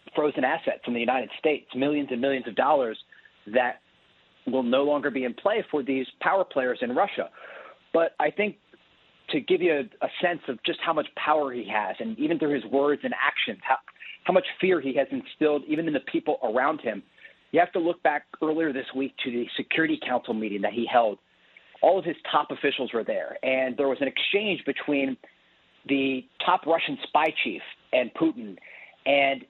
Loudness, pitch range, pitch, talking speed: -26 LUFS, 130-165 Hz, 145 Hz, 195 wpm